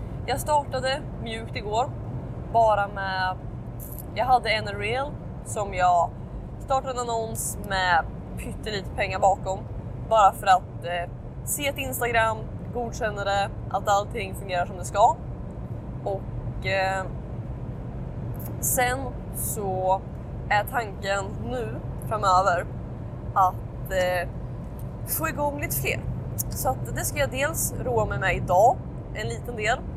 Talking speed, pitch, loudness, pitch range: 120 wpm, 180 Hz, -26 LUFS, 130-205 Hz